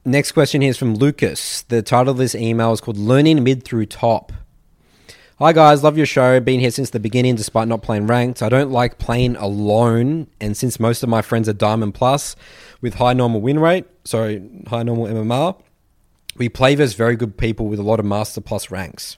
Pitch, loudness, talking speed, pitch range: 120 Hz, -17 LUFS, 210 wpm, 110-130 Hz